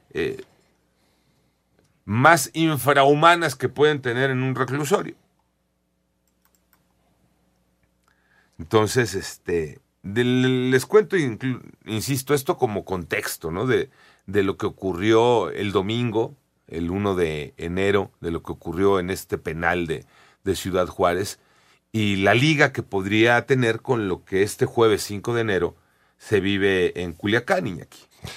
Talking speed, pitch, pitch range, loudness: 130 wpm, 110 Hz, 90-130 Hz, -22 LUFS